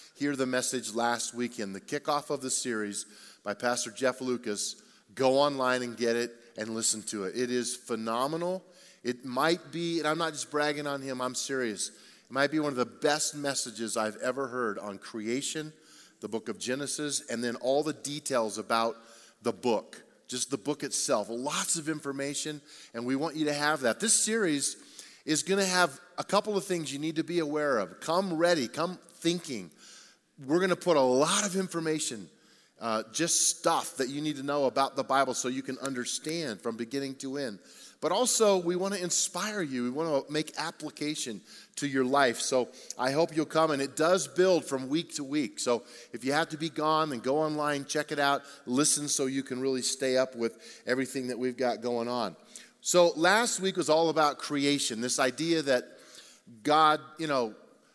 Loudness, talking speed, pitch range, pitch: -30 LUFS, 200 wpm, 125-160 Hz, 140 Hz